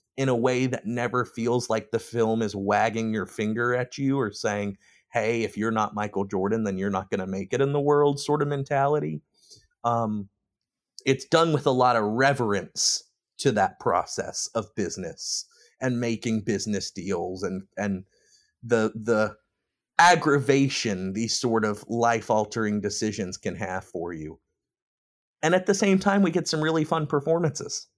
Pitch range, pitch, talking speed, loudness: 105-140 Hz, 115 Hz, 170 wpm, -25 LUFS